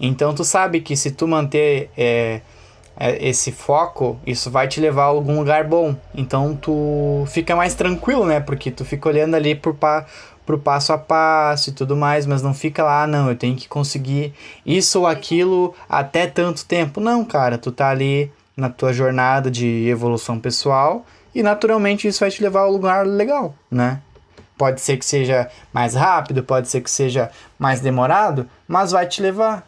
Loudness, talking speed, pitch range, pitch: -18 LUFS, 185 wpm, 130-165 Hz, 145 Hz